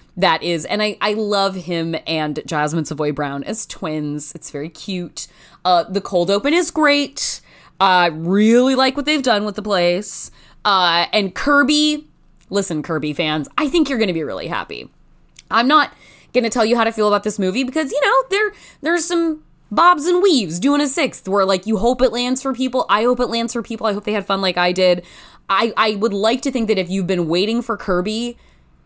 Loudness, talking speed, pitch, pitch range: -18 LUFS, 220 wpm, 210 Hz, 175-260 Hz